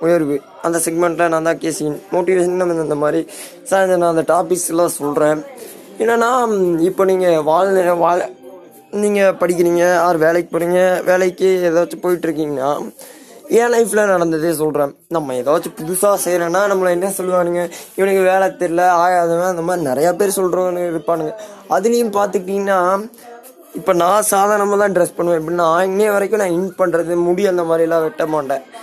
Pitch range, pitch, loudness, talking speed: 170-190 Hz, 175 Hz, -16 LUFS, 140 wpm